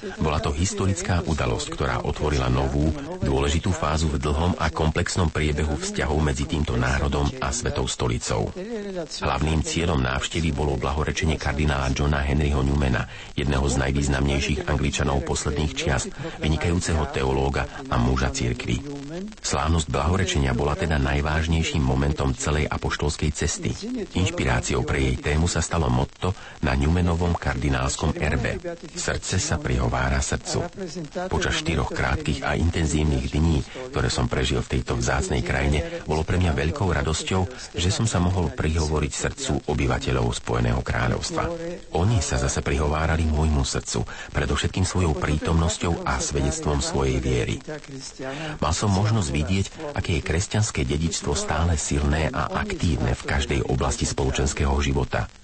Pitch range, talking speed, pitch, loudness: 70-85 Hz, 135 wpm, 75 Hz, -24 LUFS